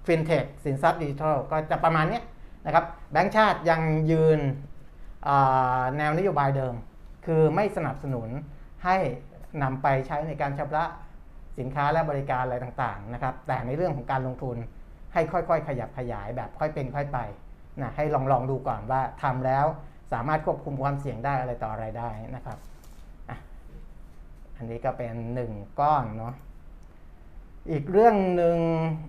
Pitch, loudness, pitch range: 135 Hz, -26 LUFS, 120-155 Hz